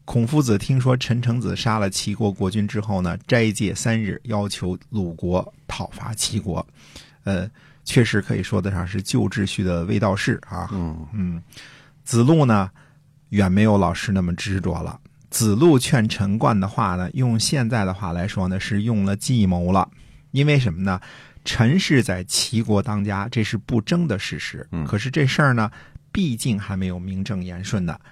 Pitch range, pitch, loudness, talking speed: 95-120 Hz, 105 Hz, -21 LUFS, 250 characters per minute